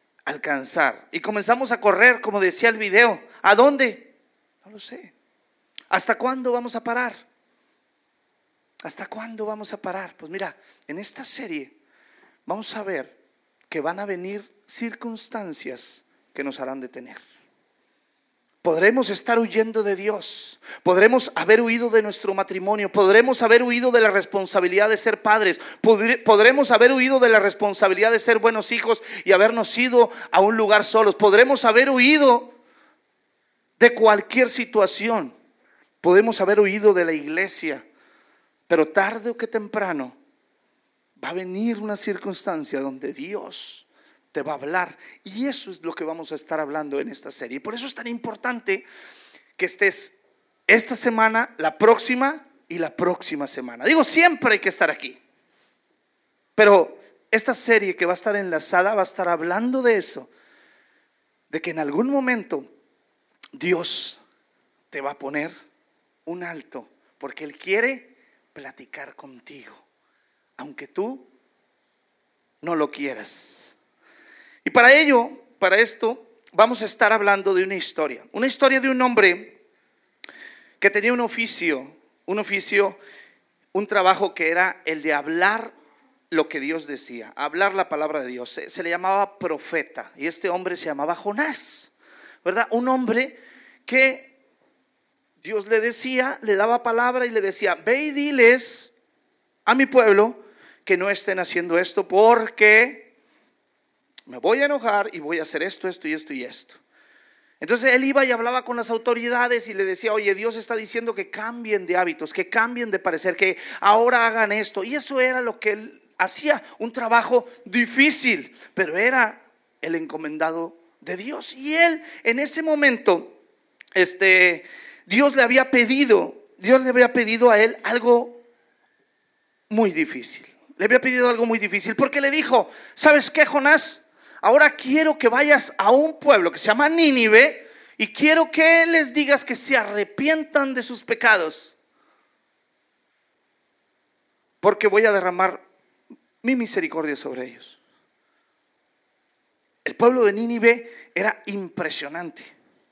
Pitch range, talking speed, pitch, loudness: 195-255 Hz, 145 wpm, 225 Hz, -19 LUFS